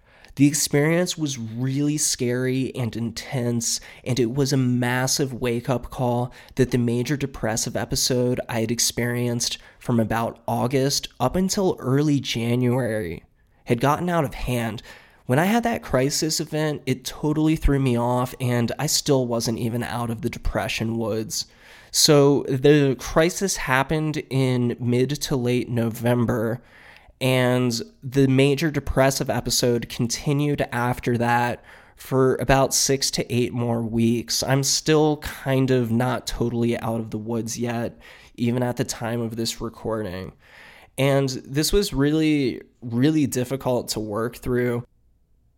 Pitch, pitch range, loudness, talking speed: 125 Hz, 120-140 Hz, -22 LUFS, 140 wpm